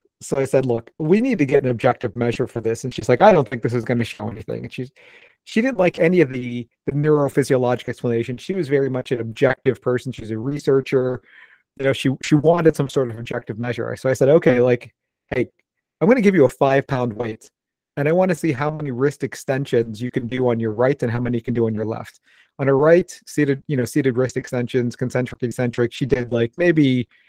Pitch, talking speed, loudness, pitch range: 130 Hz, 240 wpm, -20 LUFS, 120-145 Hz